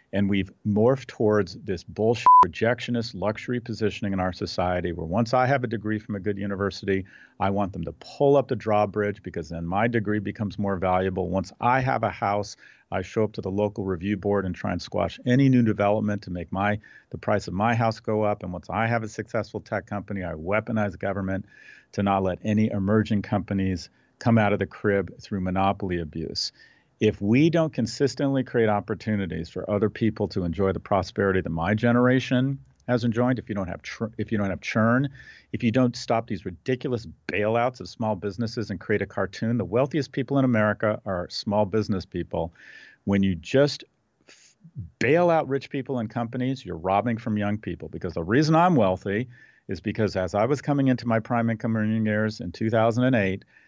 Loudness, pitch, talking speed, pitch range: -25 LUFS, 105 Hz, 200 wpm, 95-120 Hz